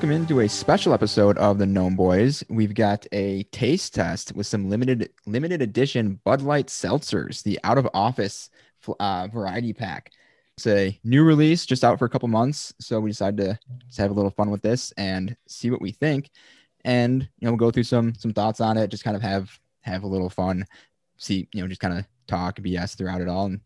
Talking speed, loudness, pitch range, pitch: 220 wpm, -23 LUFS, 100-125 Hz, 110 Hz